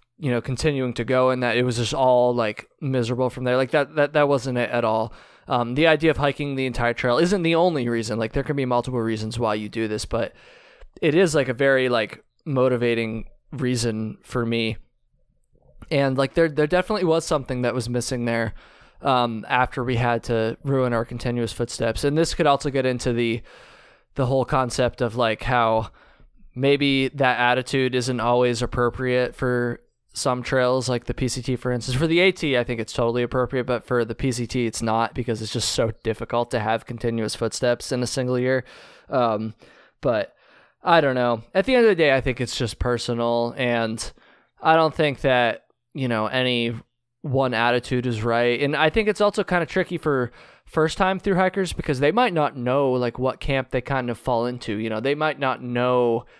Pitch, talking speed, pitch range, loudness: 125 Hz, 200 wpm, 120-140 Hz, -22 LUFS